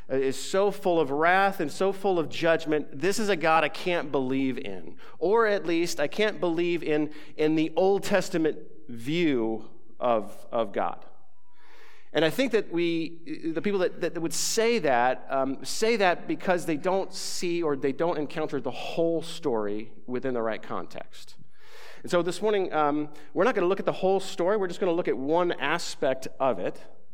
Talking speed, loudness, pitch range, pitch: 190 wpm, -27 LUFS, 150-190 Hz, 170 Hz